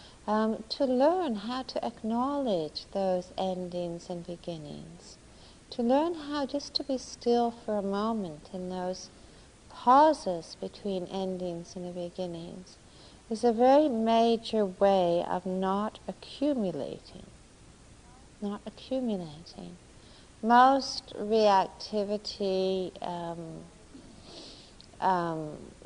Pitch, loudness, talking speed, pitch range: 200 Hz, -29 LUFS, 95 wpm, 180-240 Hz